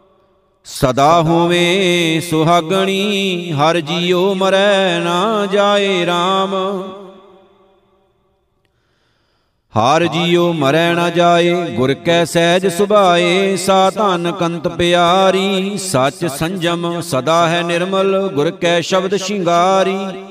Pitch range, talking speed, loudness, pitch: 170-190 Hz, 90 wpm, -14 LUFS, 175 Hz